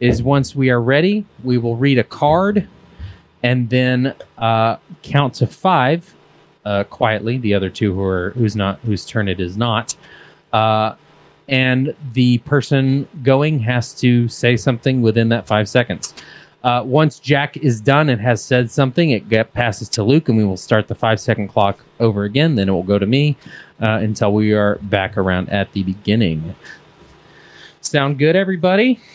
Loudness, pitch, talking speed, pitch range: -17 LUFS, 120 Hz, 175 wpm, 105-140 Hz